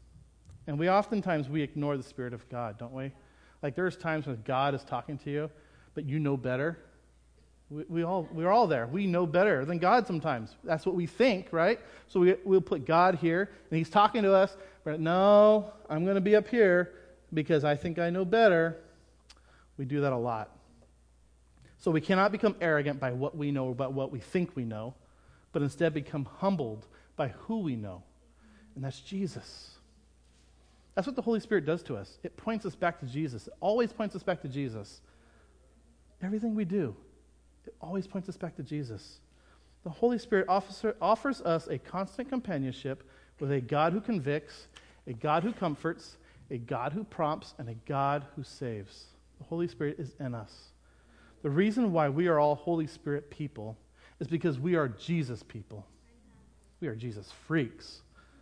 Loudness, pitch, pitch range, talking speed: -30 LUFS, 150 Hz, 120-185 Hz, 185 wpm